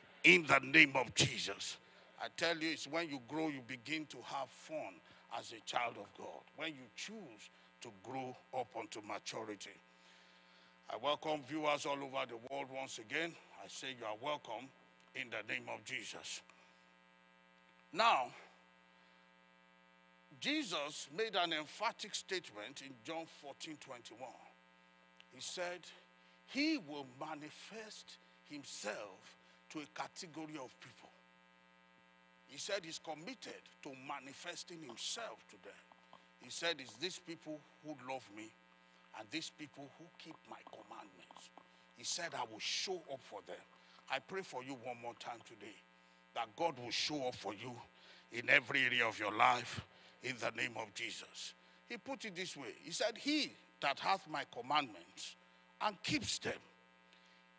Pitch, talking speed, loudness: 120 Hz, 145 wpm, -40 LUFS